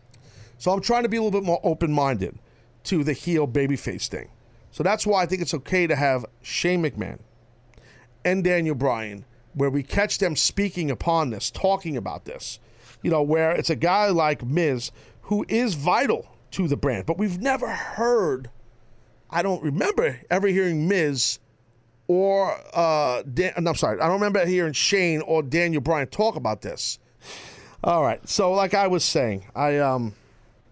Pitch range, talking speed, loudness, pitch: 120-180 Hz, 175 wpm, -23 LUFS, 155 Hz